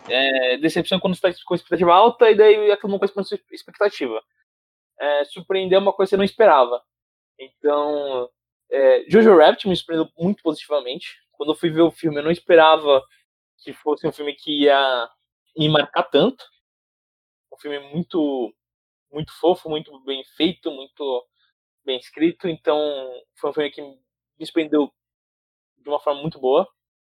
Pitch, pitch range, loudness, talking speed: 155 Hz, 135-180 Hz, -19 LUFS, 155 wpm